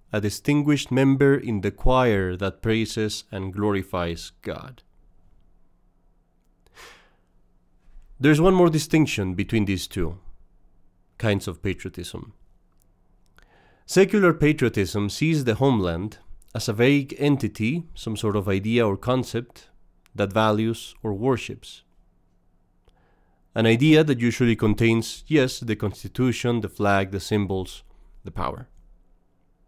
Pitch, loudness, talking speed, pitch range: 105 Hz, -23 LUFS, 110 wpm, 95-125 Hz